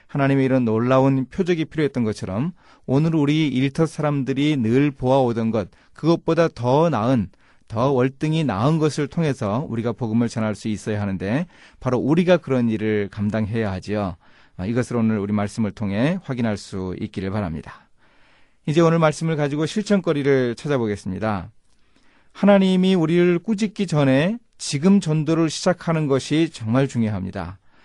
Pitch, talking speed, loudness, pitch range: 135 Hz, 345 characters per minute, -21 LUFS, 110-160 Hz